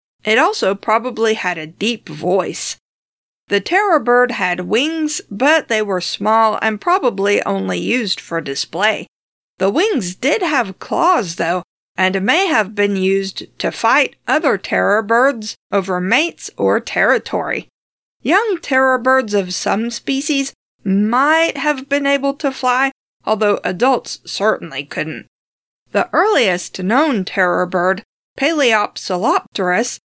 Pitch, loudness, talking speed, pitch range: 220 Hz, -16 LUFS, 130 wpm, 190-275 Hz